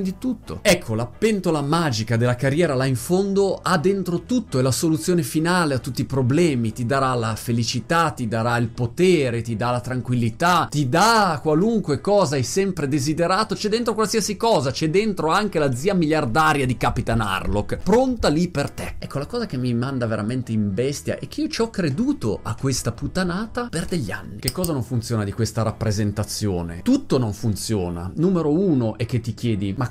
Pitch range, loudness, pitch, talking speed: 120-180 Hz, -21 LUFS, 140 Hz, 195 wpm